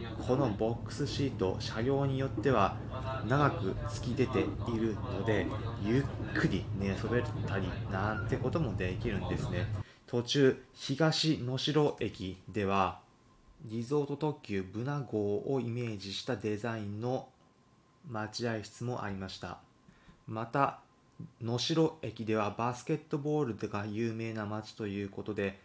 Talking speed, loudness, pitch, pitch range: 265 characters per minute, -34 LUFS, 115 Hz, 105-130 Hz